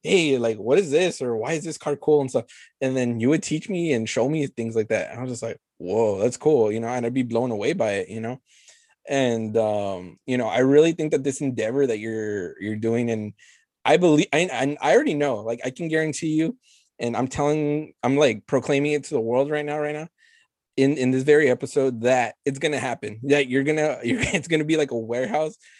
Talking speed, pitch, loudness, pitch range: 245 wpm, 135 Hz, -23 LUFS, 120-150 Hz